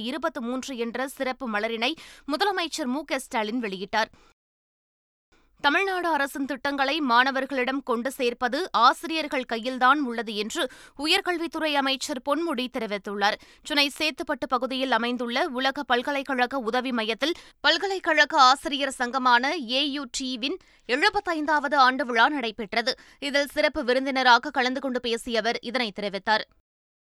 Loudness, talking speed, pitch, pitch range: -25 LUFS, 115 wpm, 270 Hz, 245-295 Hz